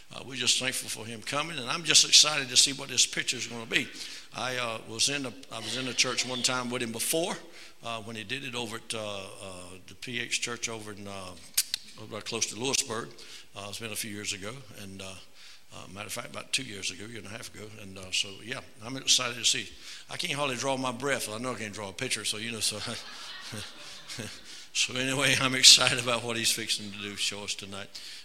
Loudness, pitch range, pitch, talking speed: -27 LUFS, 105-130 Hz, 115 Hz, 245 wpm